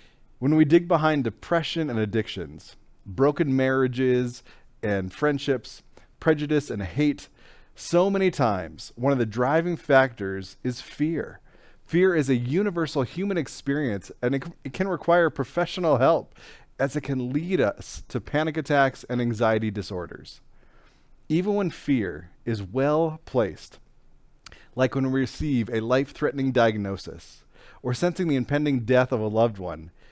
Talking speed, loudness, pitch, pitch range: 140 wpm, -25 LUFS, 135 Hz, 115-155 Hz